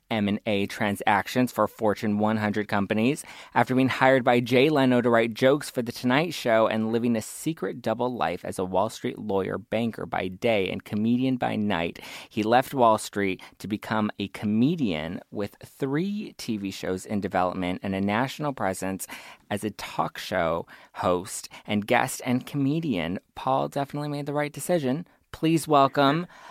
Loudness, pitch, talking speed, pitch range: -26 LUFS, 115 Hz, 165 wpm, 105-135 Hz